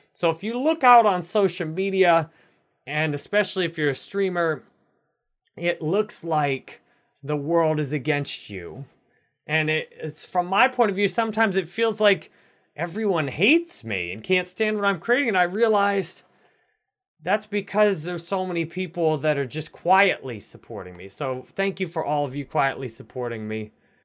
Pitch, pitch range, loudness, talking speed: 175 Hz, 150-200 Hz, -23 LUFS, 170 wpm